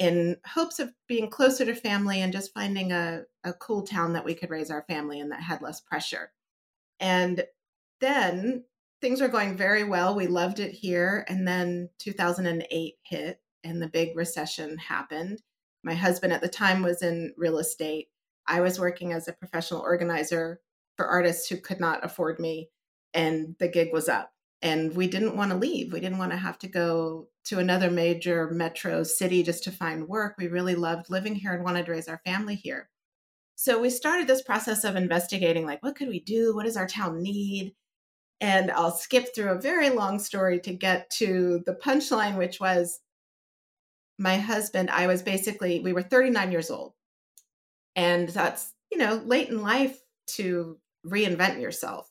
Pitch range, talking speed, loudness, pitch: 170-210 Hz, 185 wpm, -27 LUFS, 180 Hz